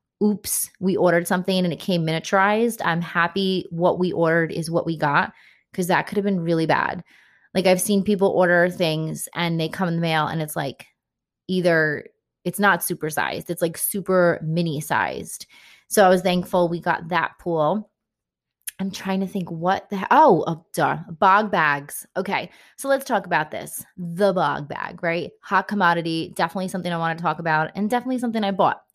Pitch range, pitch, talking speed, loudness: 165-195 Hz, 175 Hz, 190 wpm, -22 LUFS